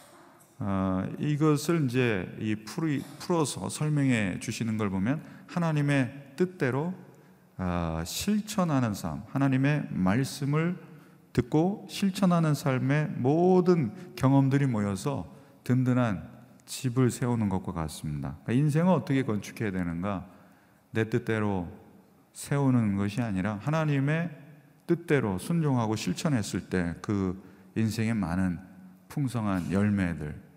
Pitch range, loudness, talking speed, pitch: 100-150 Hz, -28 LUFS, 255 characters per minute, 125 Hz